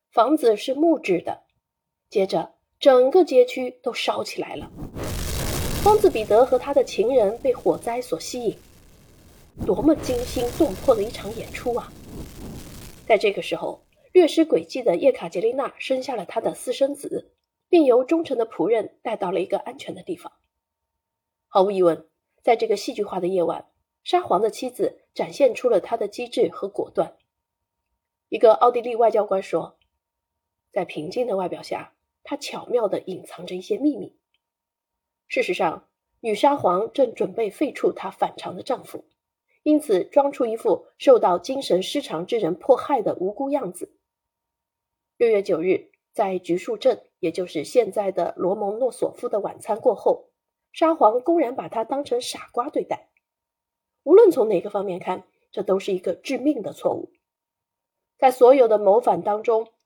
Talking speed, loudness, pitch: 240 characters per minute, -22 LUFS, 260 Hz